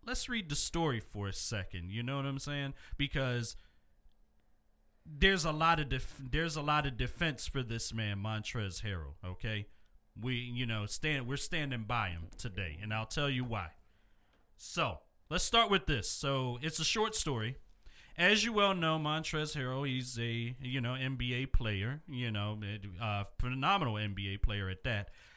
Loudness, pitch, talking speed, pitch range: -35 LUFS, 125 Hz, 175 wpm, 105-145 Hz